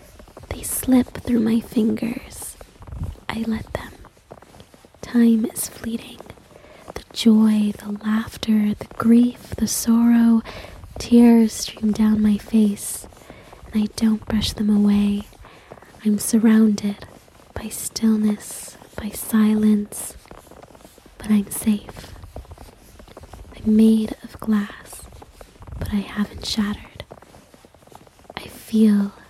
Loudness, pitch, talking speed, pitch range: -20 LUFS, 215 Hz, 100 wpm, 205-225 Hz